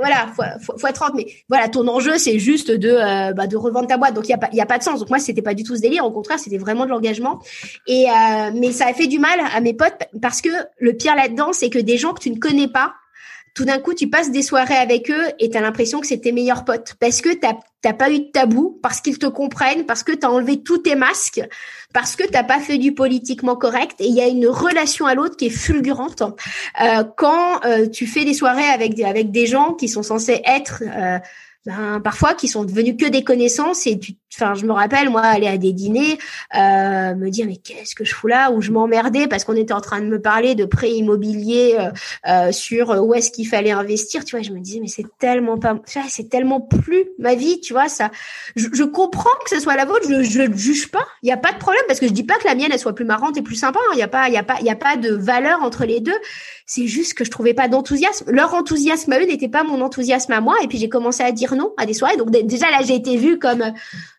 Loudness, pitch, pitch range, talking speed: -17 LUFS, 250 Hz, 225-285 Hz, 275 wpm